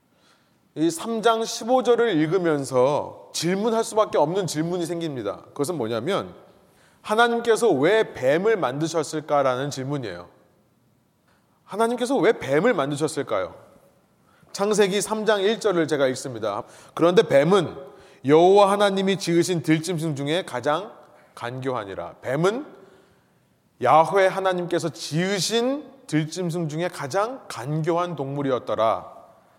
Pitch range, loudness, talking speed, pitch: 150-210 Hz, -22 LUFS, 265 characters per minute, 175 Hz